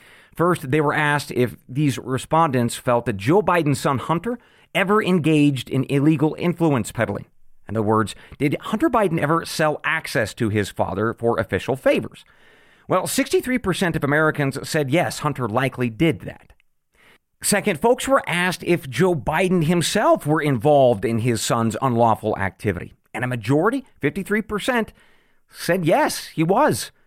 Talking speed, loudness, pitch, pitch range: 150 wpm, -21 LUFS, 150 Hz, 120-175 Hz